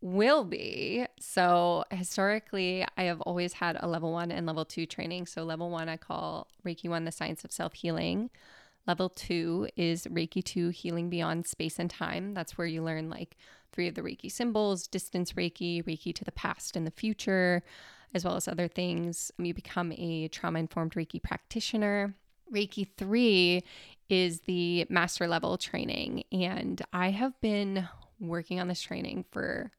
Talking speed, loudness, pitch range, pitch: 170 wpm, -32 LUFS, 170-195 Hz, 175 Hz